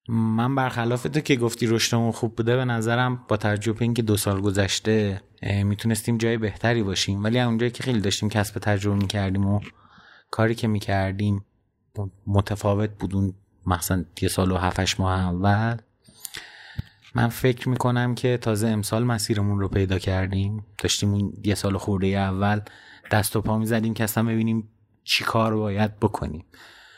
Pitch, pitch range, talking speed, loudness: 105 Hz, 100-115 Hz, 155 wpm, -24 LUFS